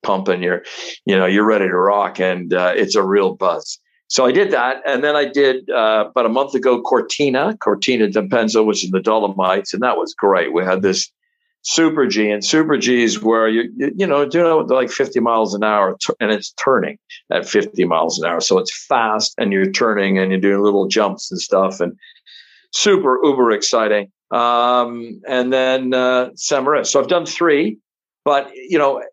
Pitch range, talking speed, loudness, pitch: 105-140 Hz, 200 wpm, -16 LUFS, 120 Hz